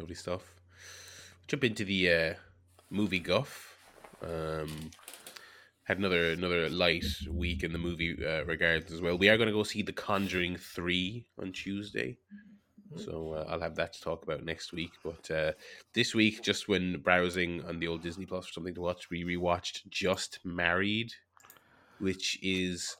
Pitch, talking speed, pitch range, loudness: 90 Hz, 165 wpm, 85-95 Hz, -32 LUFS